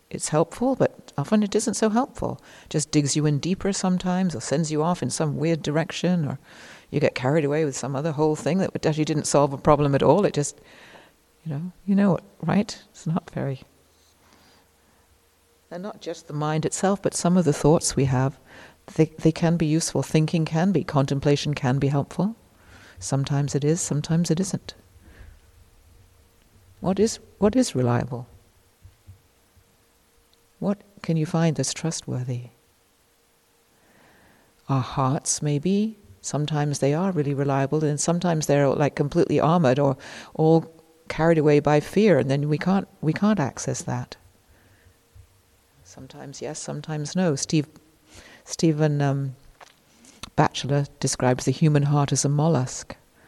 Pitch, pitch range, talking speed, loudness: 145 Hz, 125-165 Hz, 155 wpm, -23 LUFS